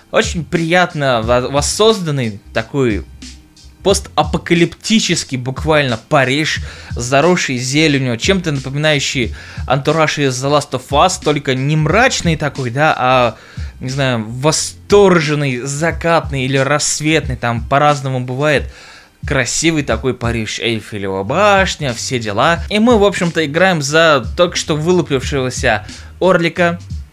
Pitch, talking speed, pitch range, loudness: 140 Hz, 110 wpm, 120-165 Hz, -14 LUFS